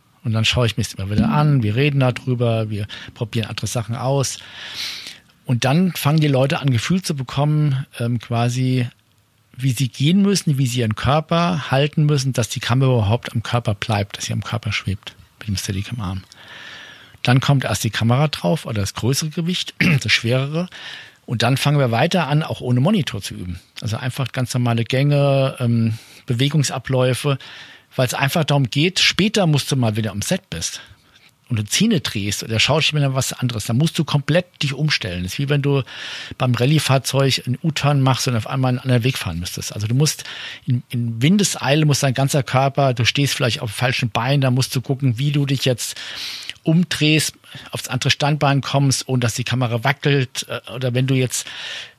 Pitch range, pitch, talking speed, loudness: 115-145 Hz, 130 Hz, 195 wpm, -19 LUFS